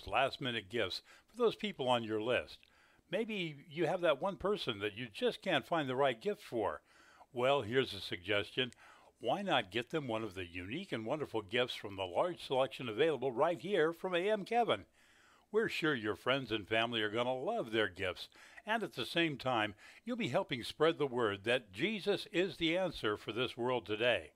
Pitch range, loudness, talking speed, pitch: 110-180 Hz, -36 LUFS, 200 wpm, 130 Hz